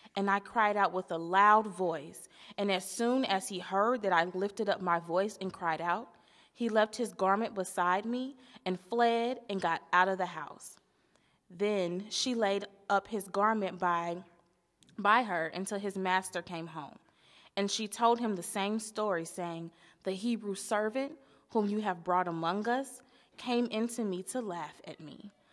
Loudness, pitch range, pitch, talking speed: -32 LUFS, 180-215 Hz, 195 Hz, 175 wpm